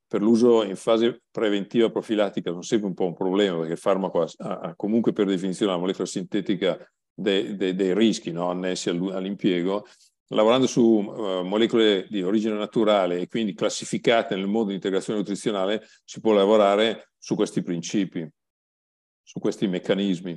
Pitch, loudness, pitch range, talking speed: 100 Hz, -24 LUFS, 95-110 Hz, 160 wpm